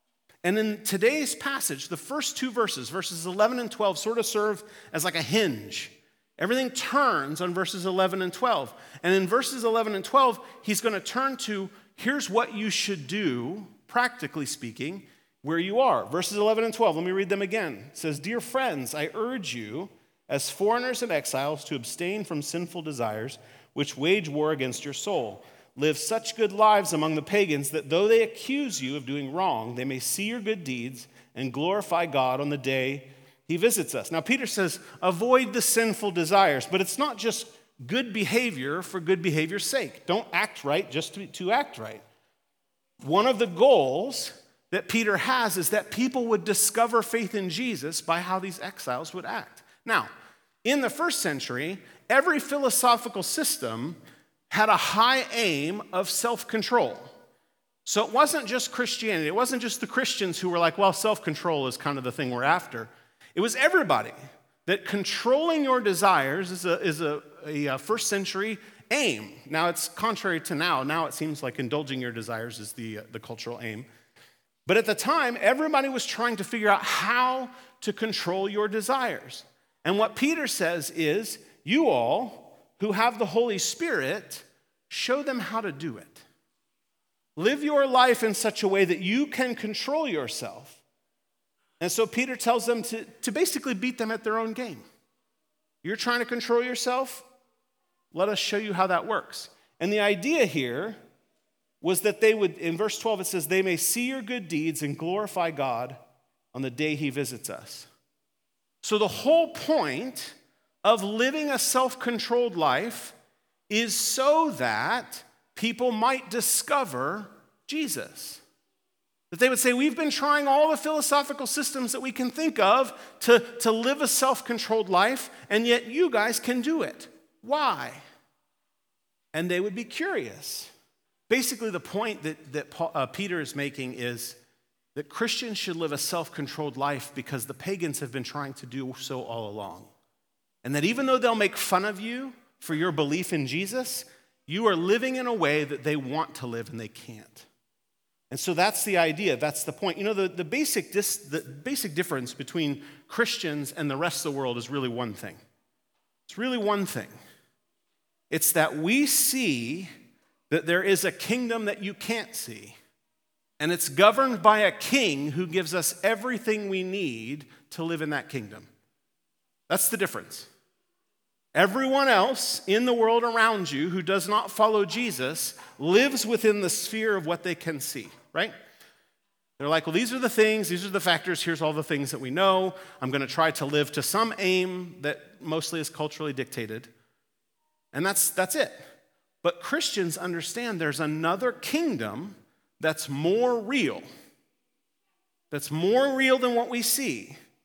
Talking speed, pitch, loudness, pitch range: 175 wpm, 200 Hz, -26 LUFS, 155-240 Hz